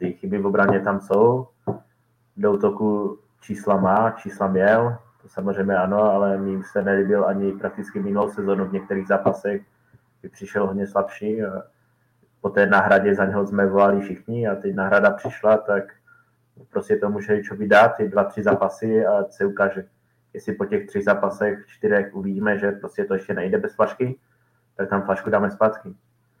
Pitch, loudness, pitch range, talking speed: 100 Hz, -21 LUFS, 100-110 Hz, 170 wpm